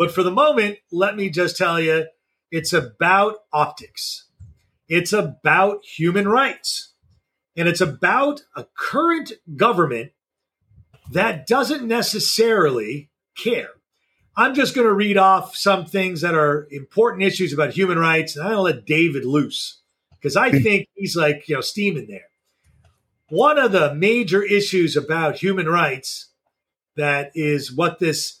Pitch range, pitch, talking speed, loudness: 160-205 Hz, 185 Hz, 140 wpm, -19 LUFS